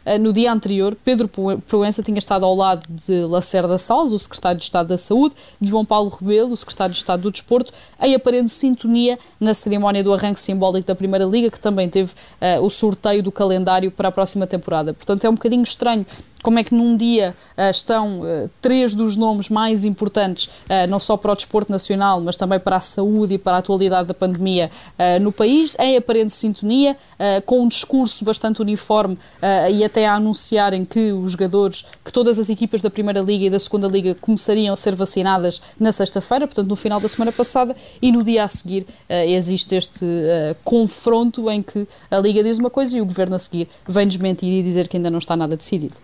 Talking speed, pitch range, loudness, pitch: 210 wpm, 185-220 Hz, -18 LUFS, 205 Hz